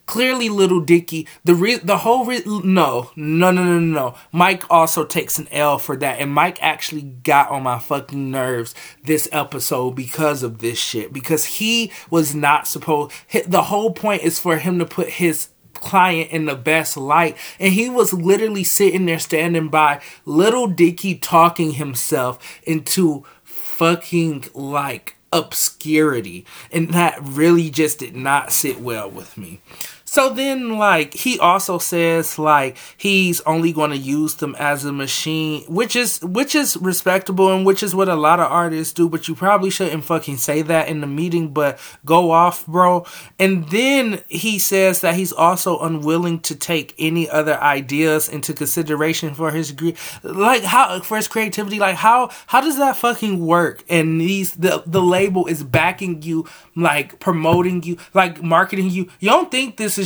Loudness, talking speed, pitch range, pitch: -17 LUFS, 170 wpm, 155-190 Hz, 170 Hz